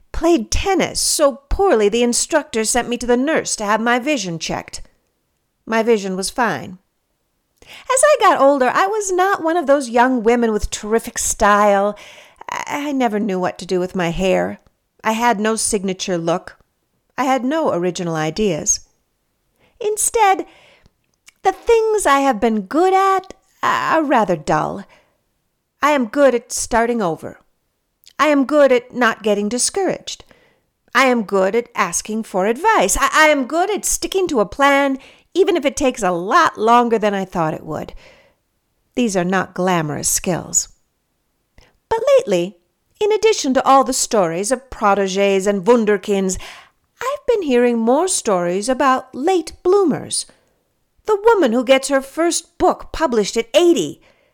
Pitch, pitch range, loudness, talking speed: 245 Hz, 205-320 Hz, -17 LUFS, 155 wpm